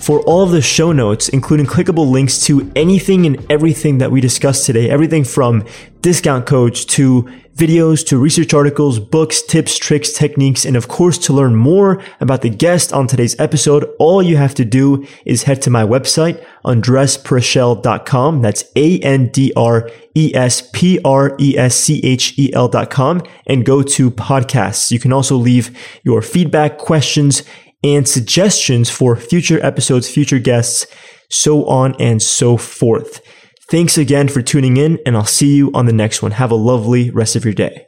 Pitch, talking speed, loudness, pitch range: 135 Hz, 160 wpm, -12 LUFS, 125-155 Hz